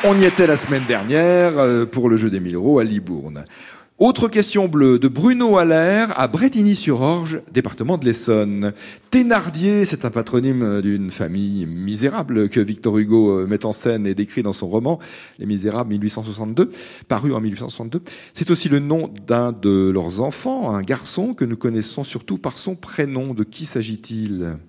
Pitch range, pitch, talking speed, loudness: 105-165 Hz, 120 Hz, 170 wpm, -19 LUFS